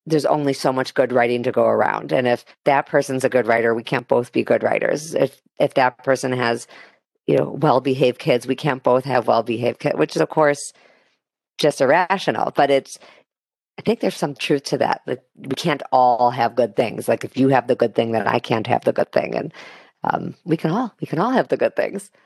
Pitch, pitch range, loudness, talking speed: 130 Hz, 120-145 Hz, -20 LUFS, 230 wpm